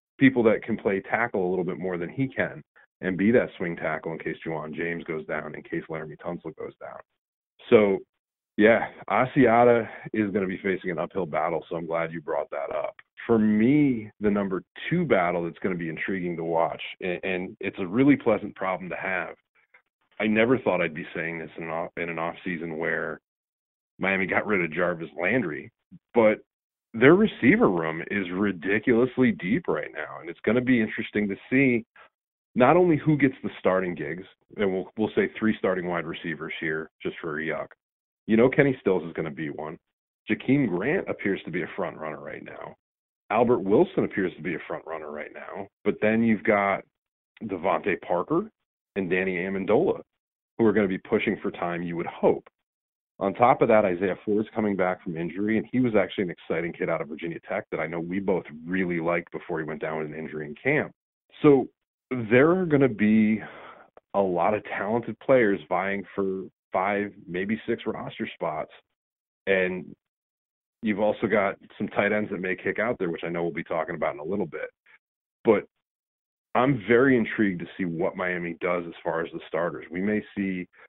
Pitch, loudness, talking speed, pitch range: 95 Hz, -26 LUFS, 200 wpm, 85-110 Hz